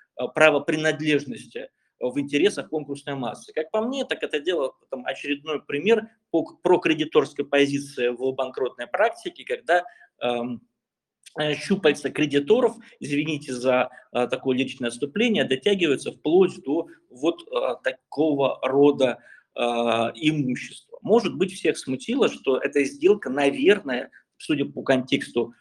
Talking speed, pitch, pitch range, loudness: 120 wpm, 145 Hz, 130-220 Hz, -24 LUFS